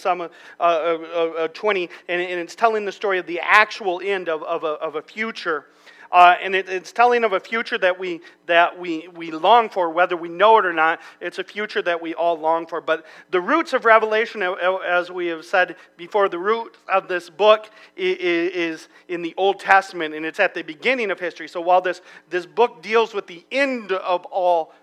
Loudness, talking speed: -20 LUFS, 220 wpm